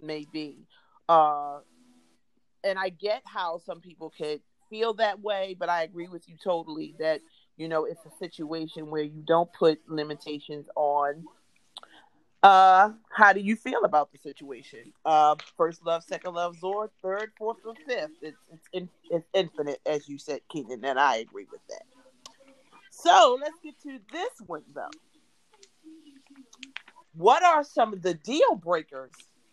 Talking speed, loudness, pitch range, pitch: 155 wpm, -25 LUFS, 155-235 Hz, 175 Hz